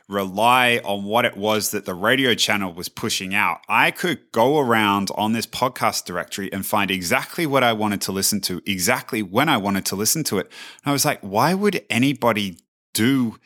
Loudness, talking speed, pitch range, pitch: -20 LUFS, 200 wpm, 100-120 Hz, 110 Hz